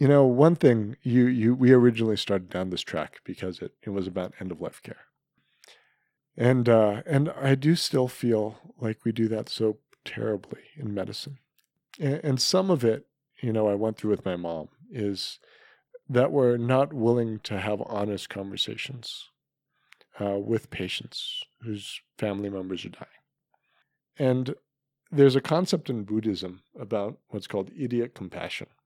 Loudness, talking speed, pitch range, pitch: -26 LUFS, 160 wpm, 105-135 Hz, 115 Hz